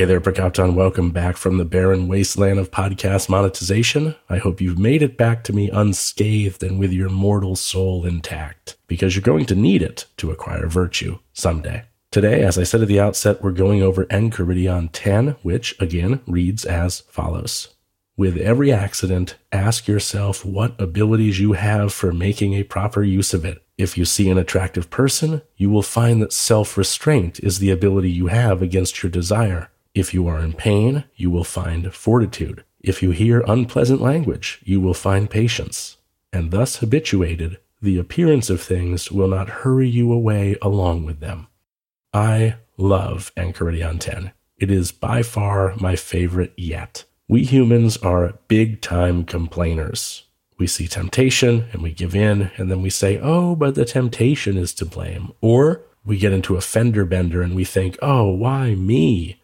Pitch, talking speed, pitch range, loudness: 95 Hz, 170 wpm, 90-110 Hz, -19 LUFS